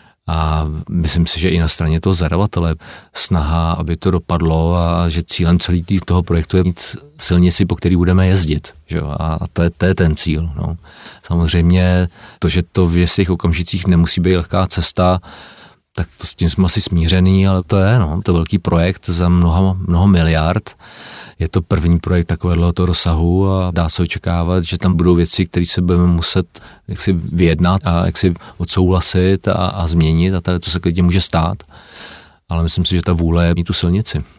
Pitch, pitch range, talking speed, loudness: 90 Hz, 85-95 Hz, 190 wpm, -15 LUFS